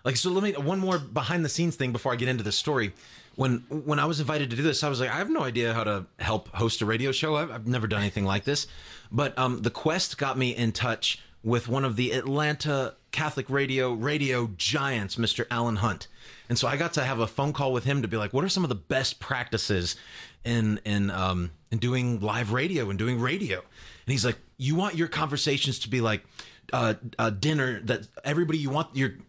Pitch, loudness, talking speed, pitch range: 130 Hz, -27 LUFS, 235 wpm, 115-145 Hz